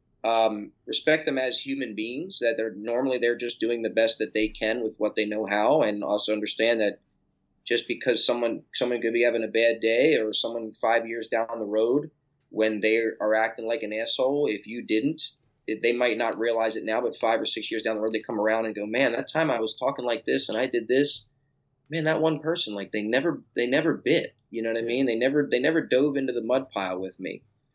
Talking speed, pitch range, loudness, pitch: 240 wpm, 110-130 Hz, -26 LUFS, 115 Hz